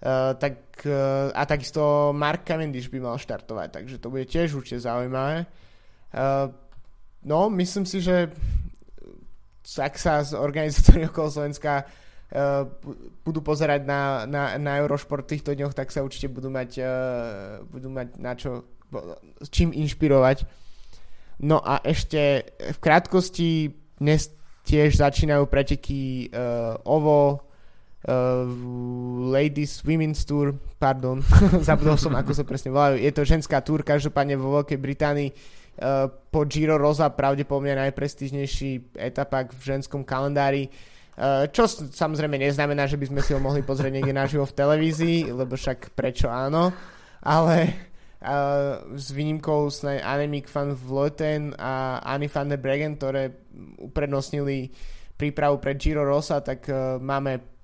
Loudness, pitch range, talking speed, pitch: -24 LUFS, 130-150 Hz, 135 wpm, 140 Hz